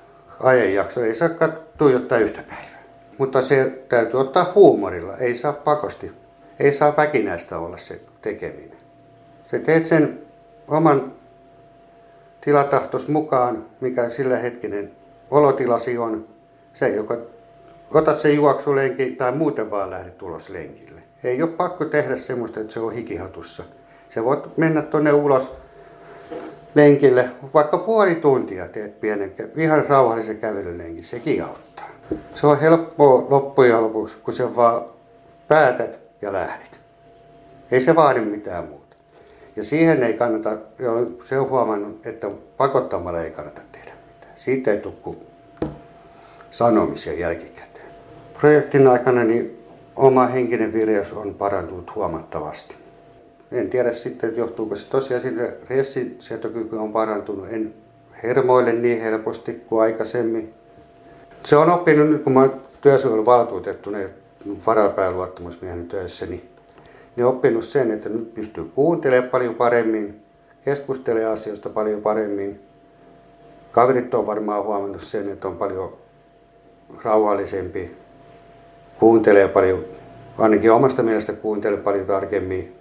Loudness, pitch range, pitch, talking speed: -20 LUFS, 105-140 Hz, 120 Hz, 125 wpm